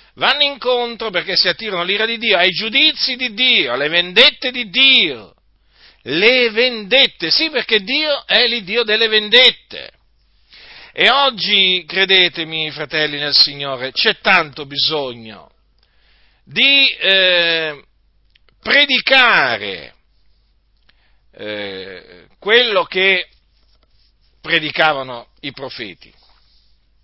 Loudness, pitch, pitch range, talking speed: -13 LUFS, 195 Hz, 160-250 Hz, 95 wpm